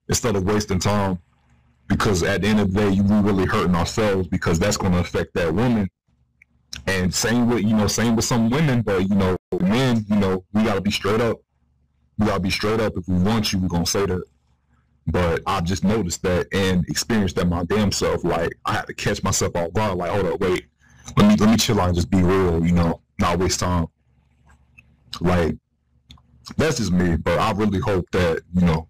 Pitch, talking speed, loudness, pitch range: 95 Hz, 215 wpm, -21 LUFS, 80-105 Hz